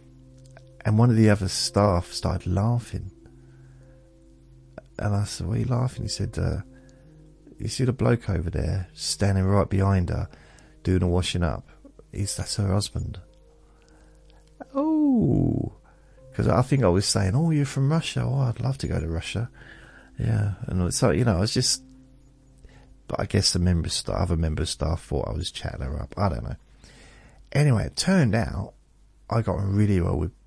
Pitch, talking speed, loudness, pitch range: 100 Hz, 175 wpm, -25 LUFS, 85-125 Hz